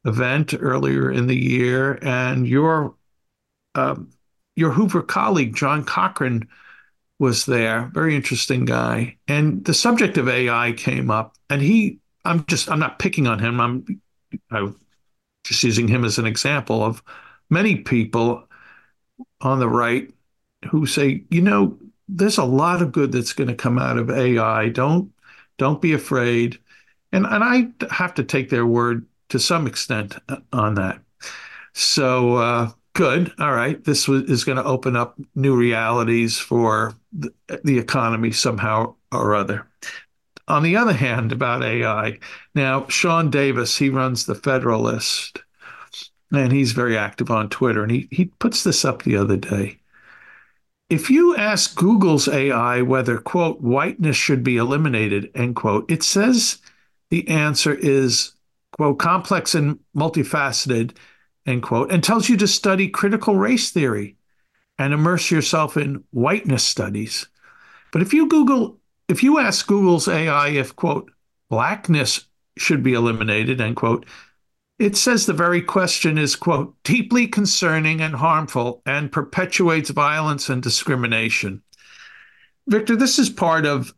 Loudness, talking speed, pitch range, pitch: -19 LUFS, 145 wpm, 120-170 Hz, 140 Hz